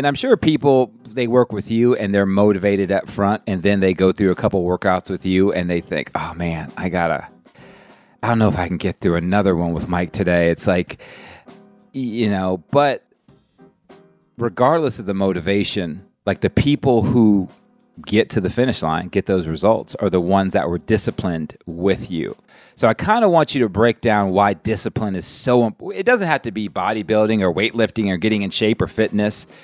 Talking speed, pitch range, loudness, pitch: 200 wpm, 95-115 Hz, -18 LUFS, 100 Hz